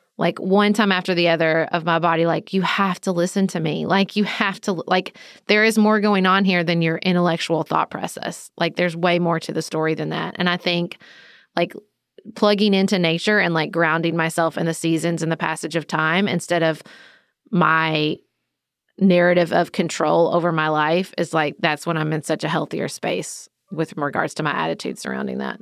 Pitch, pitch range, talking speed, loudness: 170 Hz, 160-190 Hz, 200 wpm, -20 LUFS